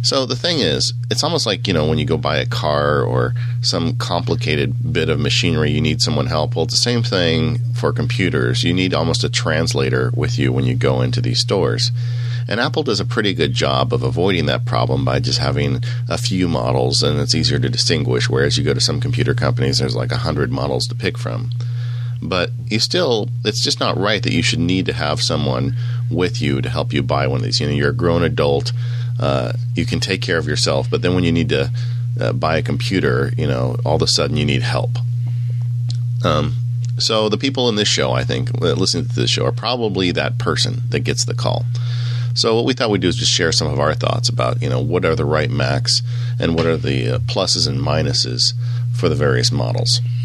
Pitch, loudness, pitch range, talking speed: 120 Hz, -17 LUFS, 120-125 Hz, 230 wpm